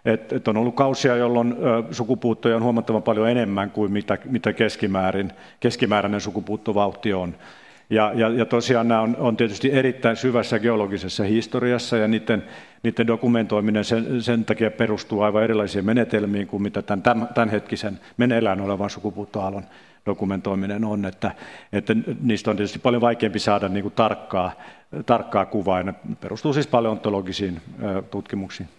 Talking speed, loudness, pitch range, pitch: 145 wpm, -22 LUFS, 100-115 Hz, 110 Hz